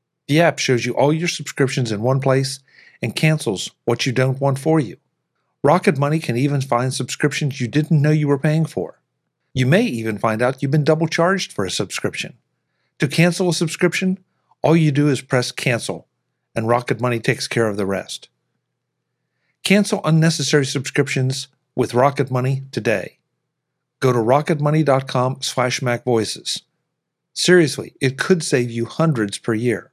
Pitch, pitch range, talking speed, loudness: 140 Hz, 125-160 Hz, 160 wpm, -19 LUFS